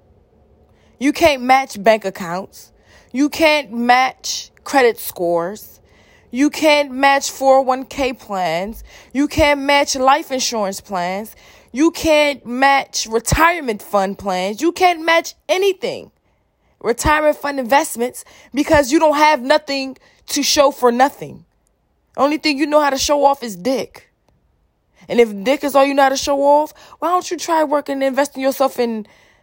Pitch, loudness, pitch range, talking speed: 275 Hz, -16 LUFS, 240-300 Hz, 150 wpm